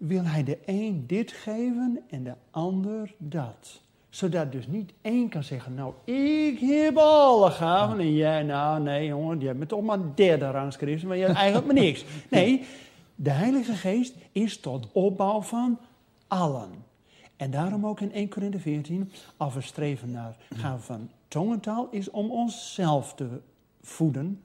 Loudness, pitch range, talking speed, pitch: -26 LUFS, 145-215 Hz, 165 wpm, 180 Hz